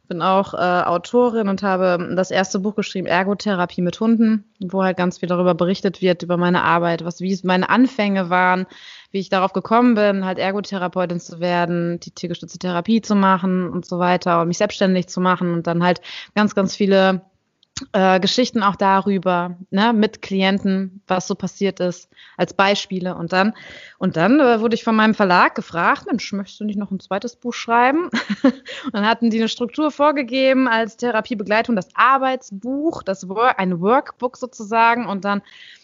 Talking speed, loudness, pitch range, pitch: 180 wpm, -19 LUFS, 180-225 Hz, 195 Hz